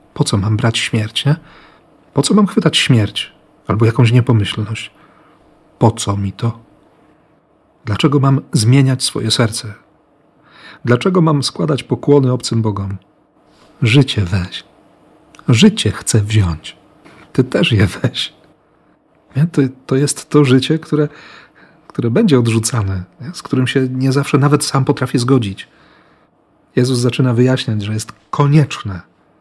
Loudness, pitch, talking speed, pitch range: -15 LUFS, 130 Hz, 125 wpm, 110-145 Hz